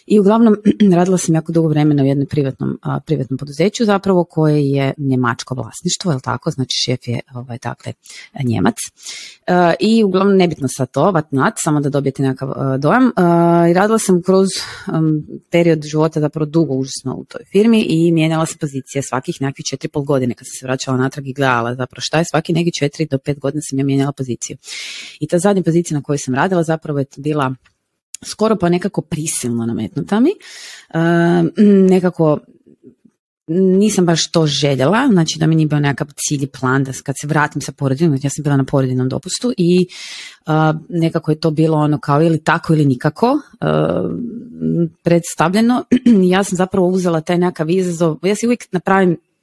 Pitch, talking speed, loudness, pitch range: 155 Hz, 175 wpm, -16 LUFS, 140-180 Hz